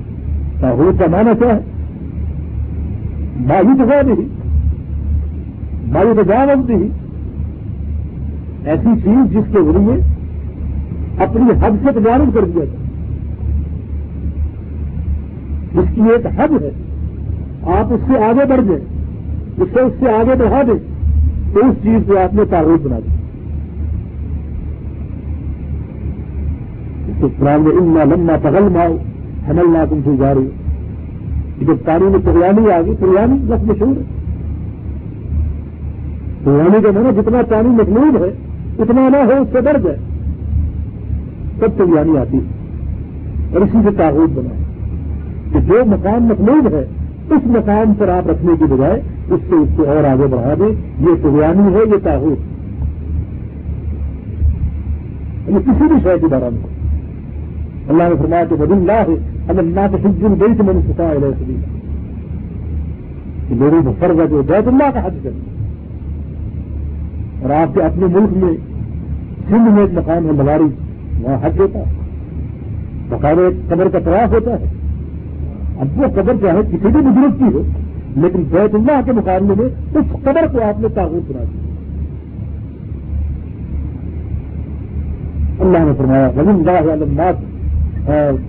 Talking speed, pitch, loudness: 130 wpm, 100 Hz, -14 LUFS